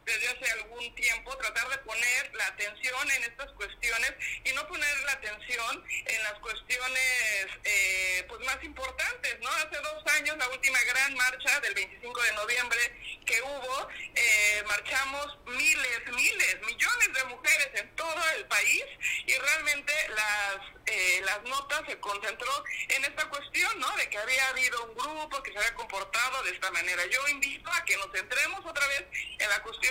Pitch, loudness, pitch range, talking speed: 260 Hz, -28 LUFS, 220-290 Hz, 170 wpm